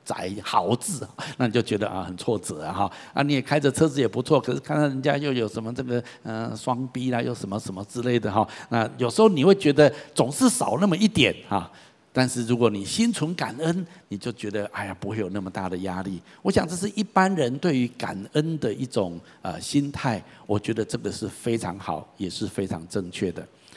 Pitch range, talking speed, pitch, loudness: 105-145 Hz, 315 characters per minute, 120 Hz, -25 LUFS